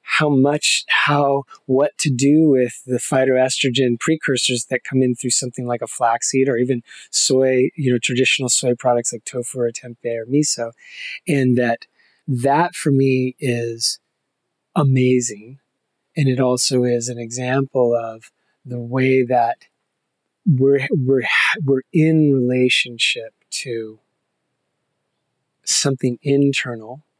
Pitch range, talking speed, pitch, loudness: 120-140 Hz, 125 wpm, 130 Hz, -18 LUFS